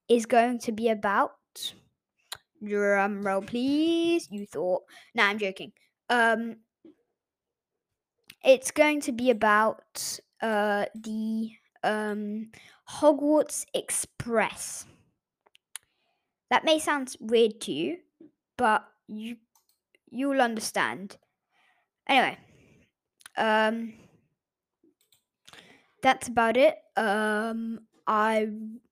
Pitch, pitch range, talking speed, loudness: 230 Hz, 215-295 Hz, 85 wpm, -26 LUFS